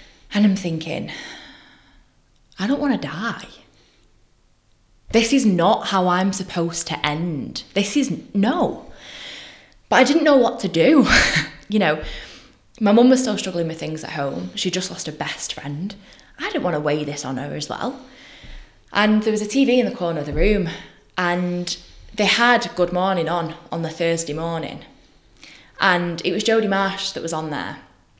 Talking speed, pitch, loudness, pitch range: 175 wpm, 180 Hz, -20 LUFS, 165-210 Hz